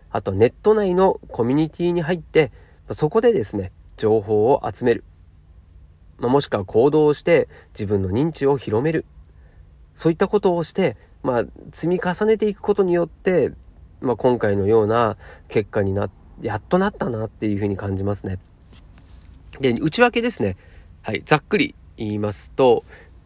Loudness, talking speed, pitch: -21 LUFS, 315 characters per minute, 110 Hz